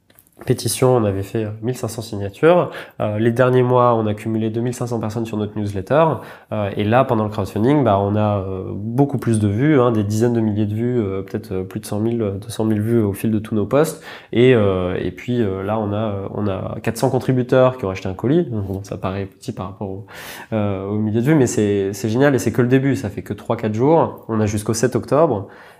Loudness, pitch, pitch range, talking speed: -19 LUFS, 110 Hz, 105-125 Hz, 235 wpm